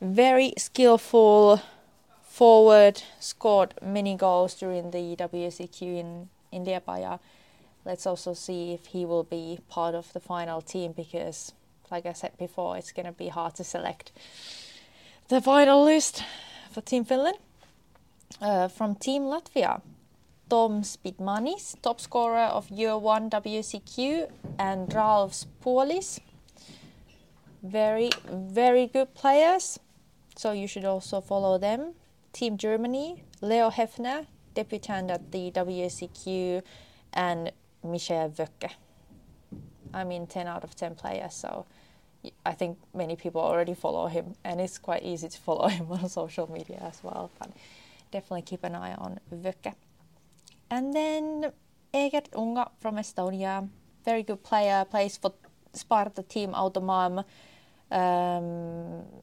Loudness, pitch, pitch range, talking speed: -27 LUFS, 195 Hz, 180-225 Hz, 130 wpm